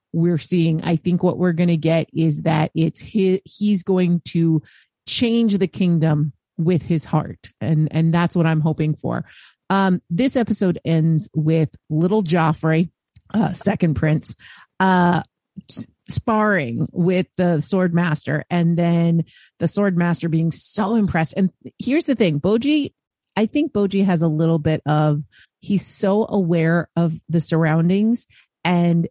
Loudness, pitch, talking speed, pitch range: -20 LUFS, 170 Hz, 150 wpm, 160-190 Hz